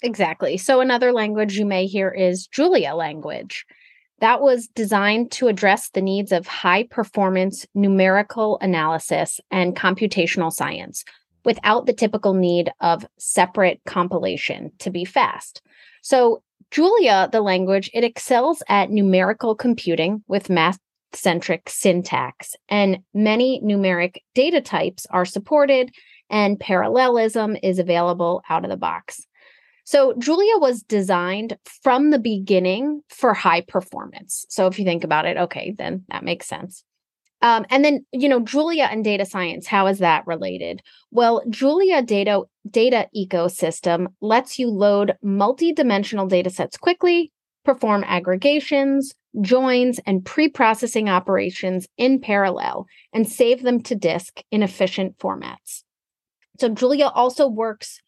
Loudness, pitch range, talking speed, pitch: -19 LUFS, 185-250 Hz, 135 wpm, 210 Hz